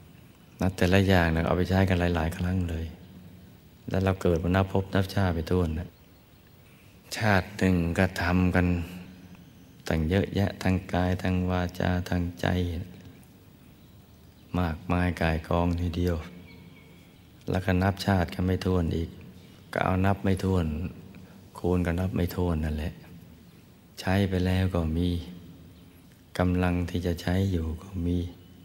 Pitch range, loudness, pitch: 85-95 Hz, -27 LUFS, 90 Hz